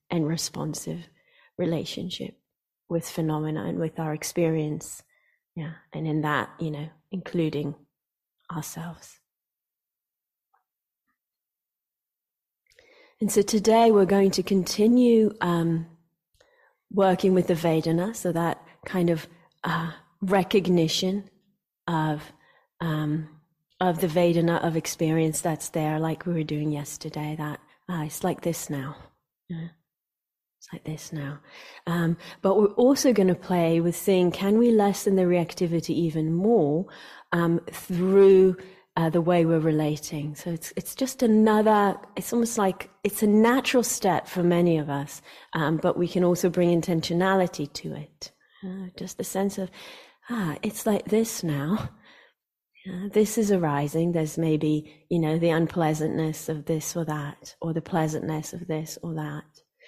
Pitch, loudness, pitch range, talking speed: 170 Hz, -25 LUFS, 155-195 Hz, 140 wpm